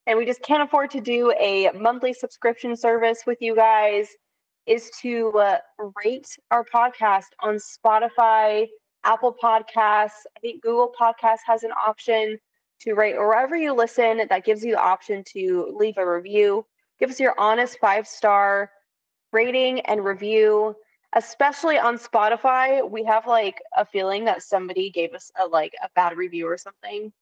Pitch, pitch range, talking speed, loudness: 225 Hz, 210-245 Hz, 160 wpm, -21 LUFS